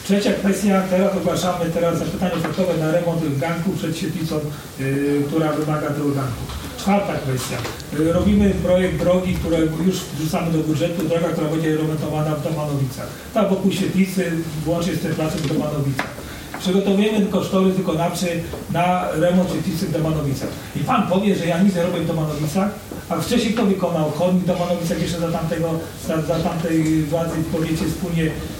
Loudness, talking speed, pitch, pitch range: -20 LUFS, 165 wpm, 170 Hz, 155-180 Hz